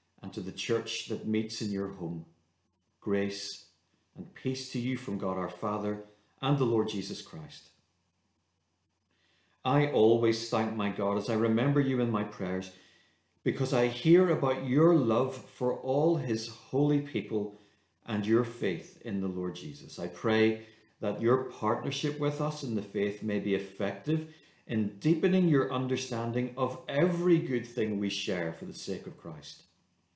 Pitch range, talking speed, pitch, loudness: 100-130 Hz, 160 wpm, 110 Hz, -30 LUFS